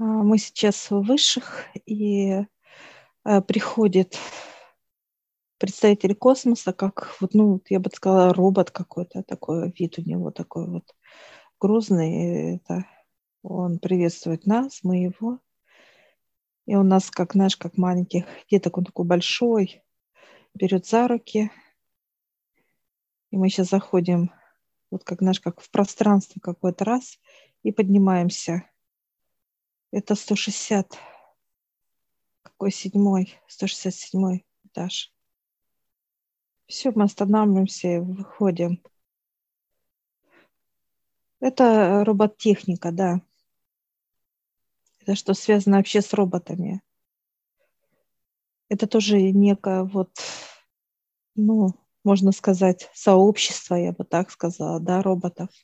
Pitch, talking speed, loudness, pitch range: 195 Hz, 100 wpm, -22 LUFS, 180-210 Hz